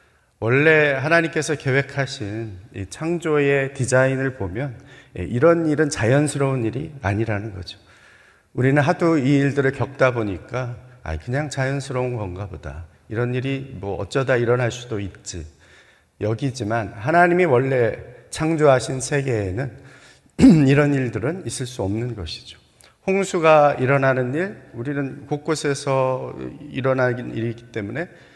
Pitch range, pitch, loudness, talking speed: 110-140 Hz, 130 Hz, -20 LUFS, 285 characters per minute